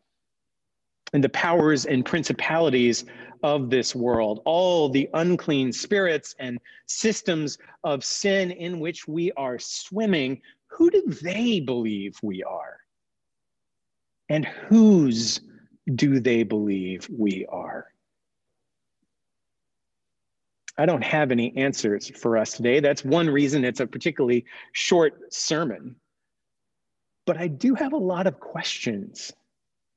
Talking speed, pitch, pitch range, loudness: 115 wpm, 145 Hz, 125-175 Hz, -24 LUFS